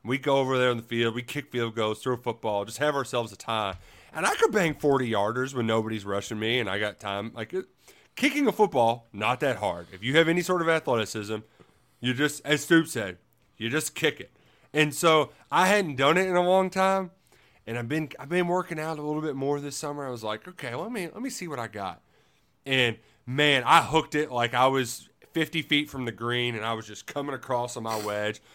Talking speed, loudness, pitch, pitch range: 240 wpm, -27 LUFS, 130 Hz, 115-155 Hz